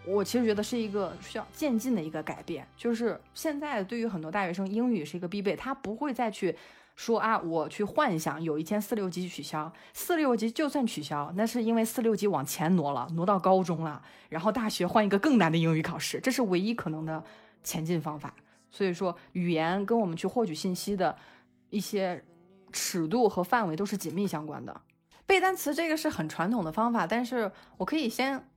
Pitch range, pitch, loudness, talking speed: 165-235 Hz, 200 Hz, -30 LUFS, 310 characters per minute